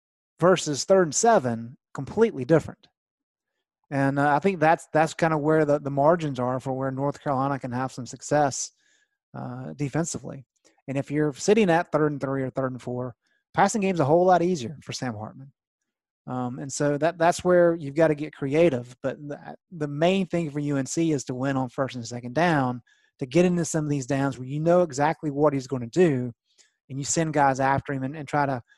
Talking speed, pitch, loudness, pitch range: 215 wpm, 145 Hz, -24 LUFS, 135-165 Hz